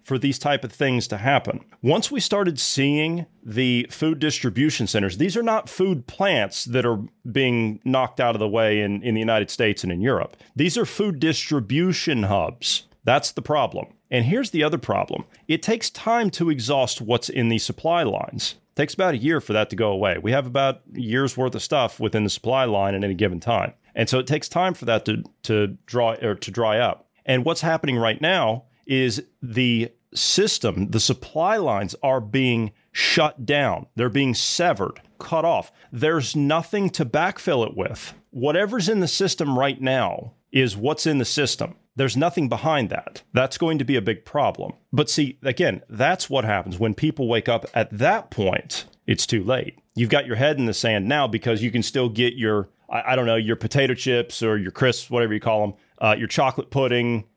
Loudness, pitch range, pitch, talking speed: -22 LUFS, 115-155 Hz, 130 Hz, 205 wpm